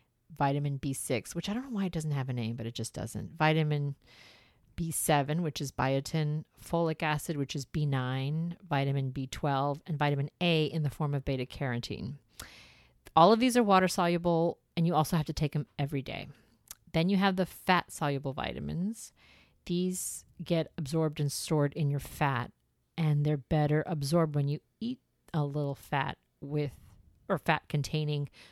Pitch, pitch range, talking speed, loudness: 150 Hz, 140-165 Hz, 170 wpm, -31 LUFS